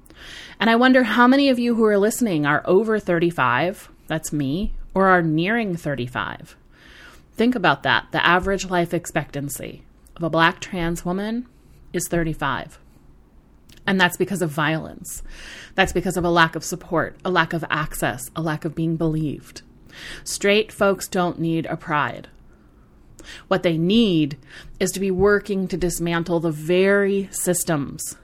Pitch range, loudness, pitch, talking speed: 155-190 Hz, -21 LUFS, 170 Hz, 155 wpm